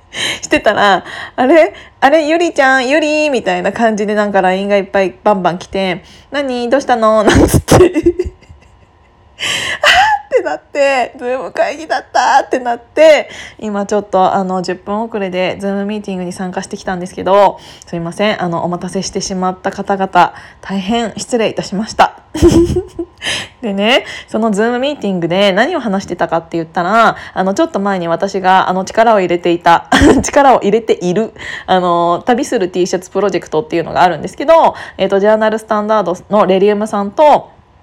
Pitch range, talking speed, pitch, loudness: 185-245 Hz, 375 characters per minute, 200 Hz, -13 LUFS